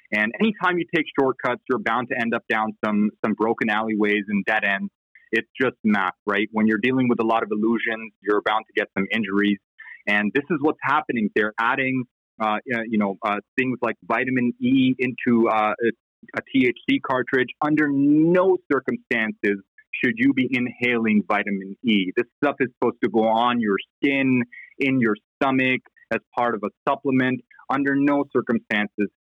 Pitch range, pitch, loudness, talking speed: 105-135 Hz, 120 Hz, -22 LUFS, 175 wpm